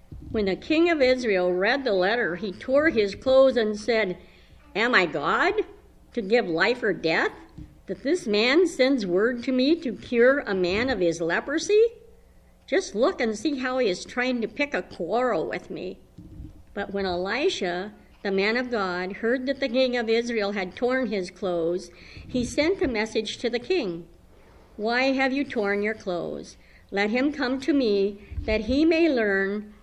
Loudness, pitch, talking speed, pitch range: -24 LUFS, 235 Hz, 180 wpm, 200-270 Hz